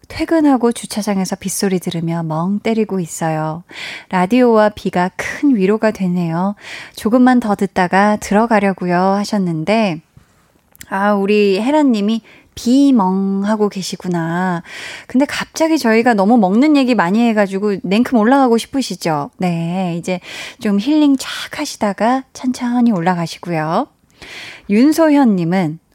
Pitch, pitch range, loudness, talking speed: 205 Hz, 185-245 Hz, -15 LUFS, 280 characters per minute